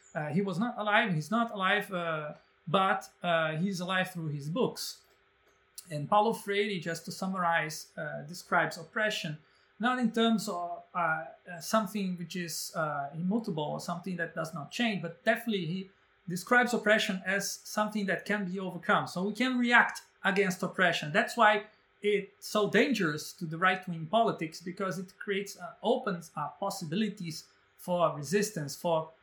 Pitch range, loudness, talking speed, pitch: 170-210 Hz, -31 LUFS, 160 wpm, 190 Hz